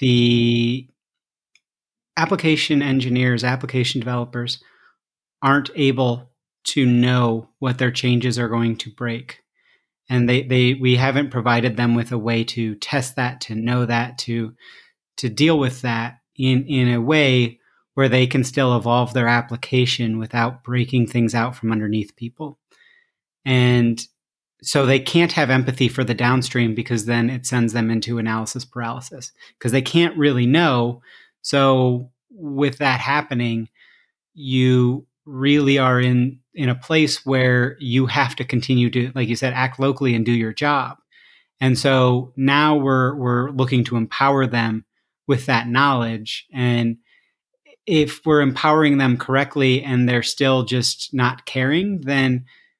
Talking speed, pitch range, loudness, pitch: 145 wpm, 120-135 Hz, -19 LUFS, 125 Hz